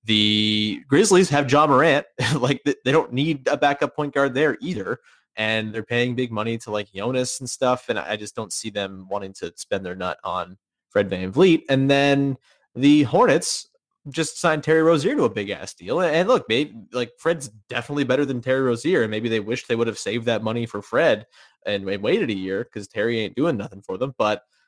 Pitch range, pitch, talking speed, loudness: 105-145 Hz, 120 Hz, 215 wpm, -22 LUFS